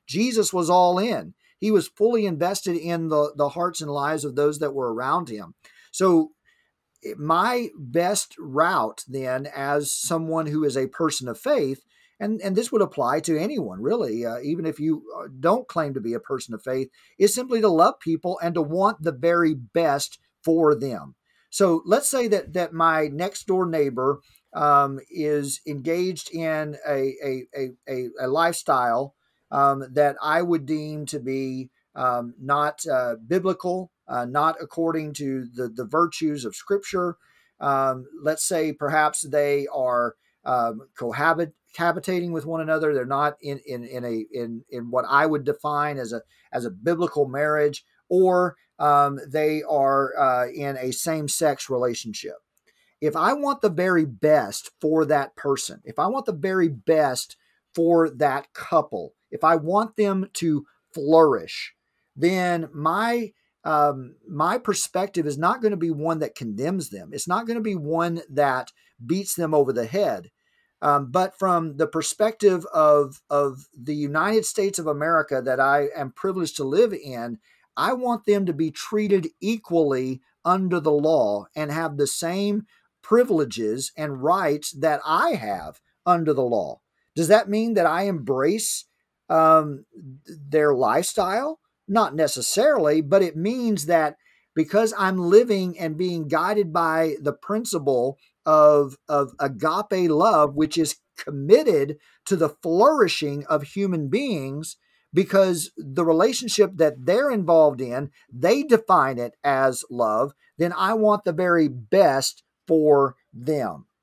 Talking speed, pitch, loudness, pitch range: 155 wpm, 160 Hz, -23 LUFS, 145-185 Hz